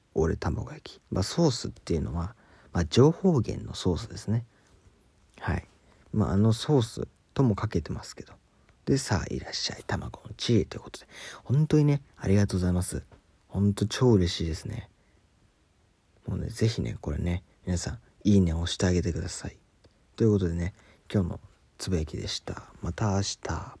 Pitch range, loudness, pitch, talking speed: 90-110 Hz, -28 LUFS, 100 Hz, 340 characters per minute